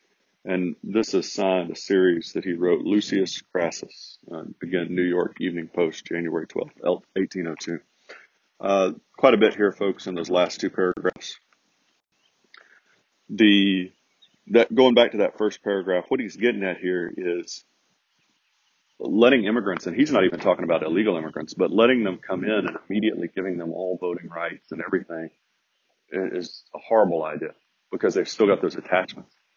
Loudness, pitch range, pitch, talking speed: -23 LUFS, 90-100 Hz, 95 Hz, 160 wpm